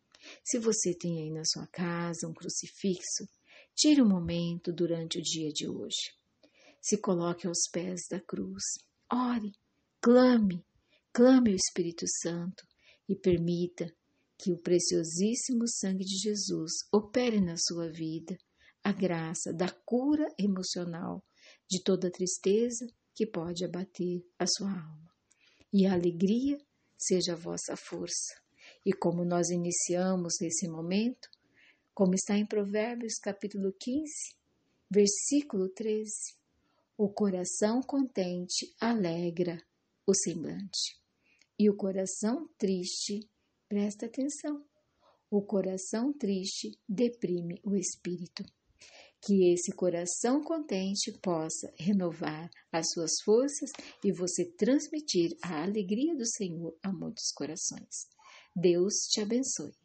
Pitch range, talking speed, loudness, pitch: 175-220 Hz, 115 wpm, -31 LUFS, 190 Hz